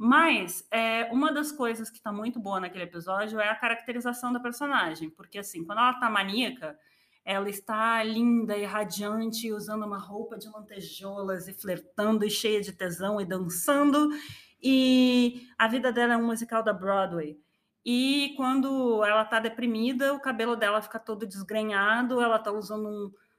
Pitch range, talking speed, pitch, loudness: 205-245 Hz, 165 wpm, 225 Hz, -27 LUFS